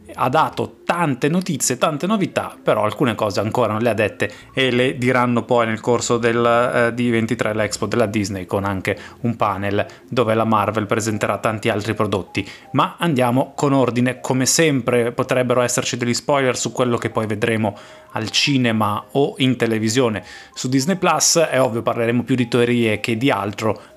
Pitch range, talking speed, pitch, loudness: 110-130 Hz, 170 wpm, 120 Hz, -19 LUFS